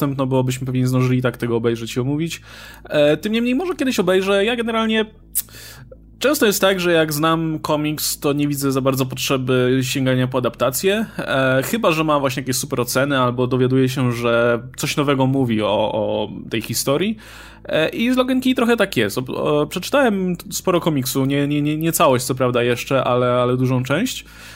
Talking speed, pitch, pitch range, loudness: 190 wpm, 140 Hz, 130-185 Hz, -19 LUFS